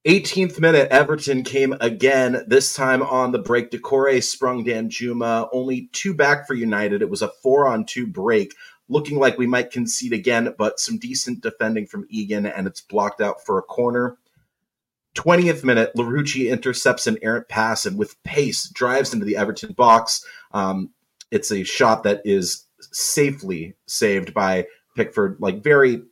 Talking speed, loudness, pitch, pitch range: 165 wpm, -20 LUFS, 125 Hz, 115-135 Hz